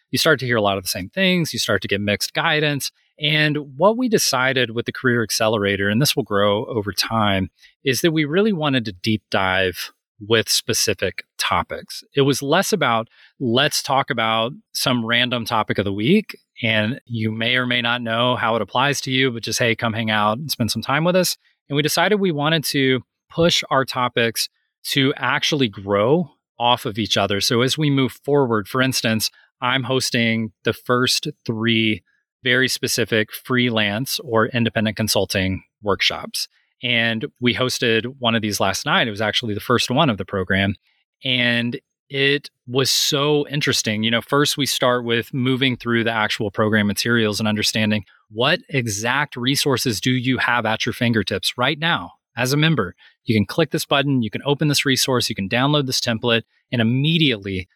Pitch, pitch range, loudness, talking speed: 120 Hz, 110-140 Hz, -19 LUFS, 185 wpm